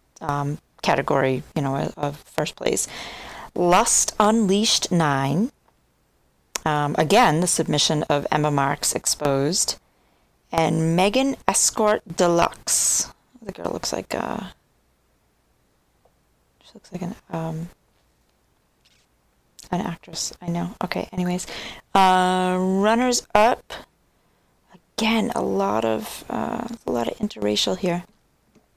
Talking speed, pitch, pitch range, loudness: 110 wpm, 165 Hz, 140-195 Hz, -22 LUFS